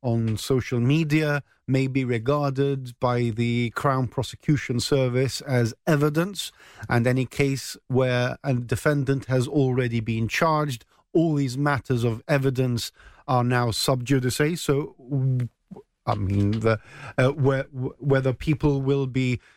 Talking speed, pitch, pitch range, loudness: 125 wpm, 130 Hz, 120-140 Hz, -24 LUFS